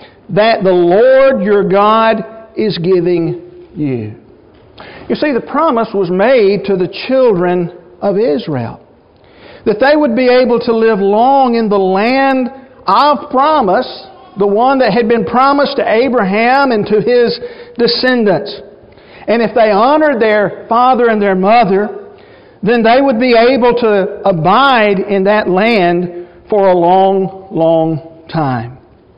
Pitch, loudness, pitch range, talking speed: 215 Hz, -11 LUFS, 190-250 Hz, 140 wpm